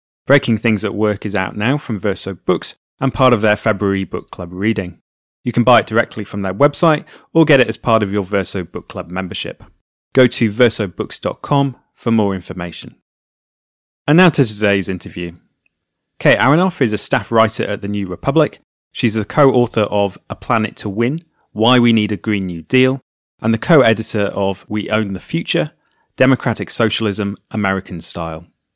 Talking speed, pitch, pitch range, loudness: 180 wpm, 105 Hz, 95-125 Hz, -16 LUFS